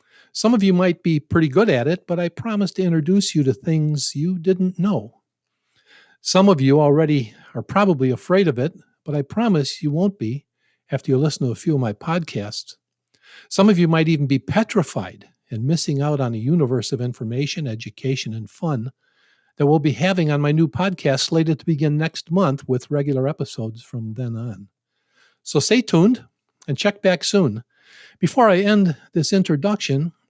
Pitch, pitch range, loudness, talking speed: 155 Hz, 135-185 Hz, -20 LUFS, 185 wpm